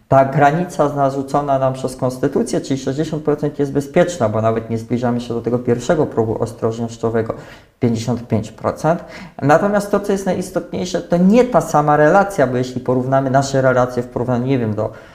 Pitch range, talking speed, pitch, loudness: 120-160 Hz, 160 wpm, 135 Hz, -17 LUFS